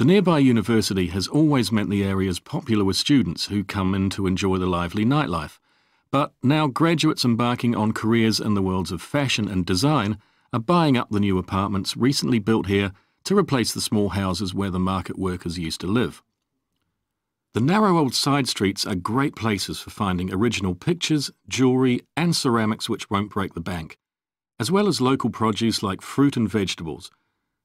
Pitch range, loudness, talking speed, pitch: 95-130 Hz, -22 LUFS, 180 wpm, 110 Hz